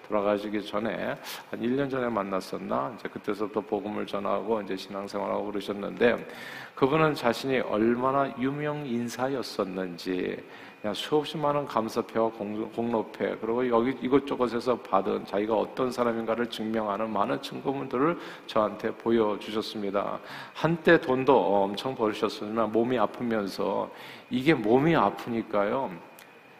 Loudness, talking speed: -28 LUFS, 315 characters per minute